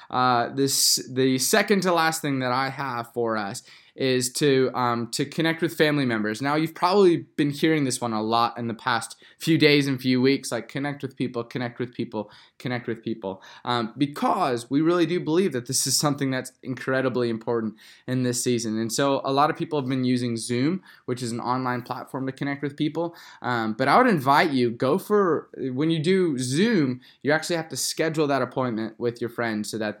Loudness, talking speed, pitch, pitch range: -24 LUFS, 210 wpm, 130 Hz, 120-150 Hz